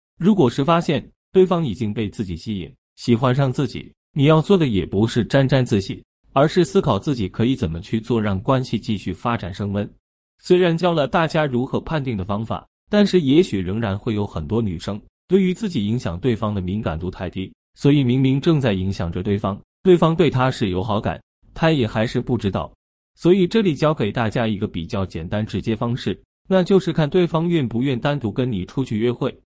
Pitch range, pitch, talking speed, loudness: 100-155 Hz, 120 Hz, 305 characters per minute, -20 LUFS